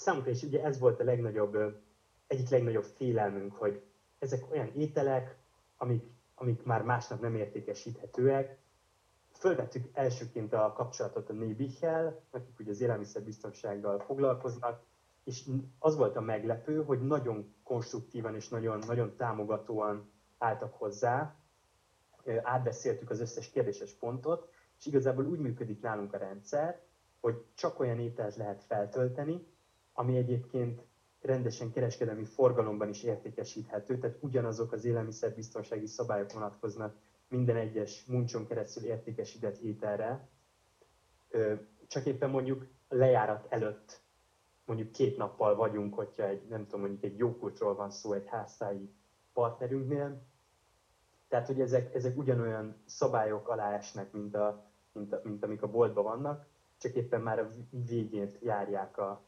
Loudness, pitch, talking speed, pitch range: -35 LUFS, 115 Hz, 130 wpm, 105-130 Hz